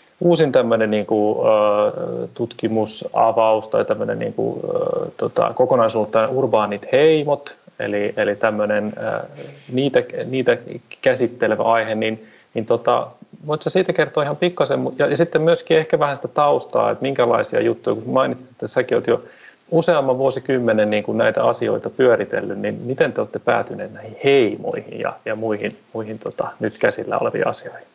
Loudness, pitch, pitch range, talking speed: -19 LUFS, 120 Hz, 110-170 Hz, 135 wpm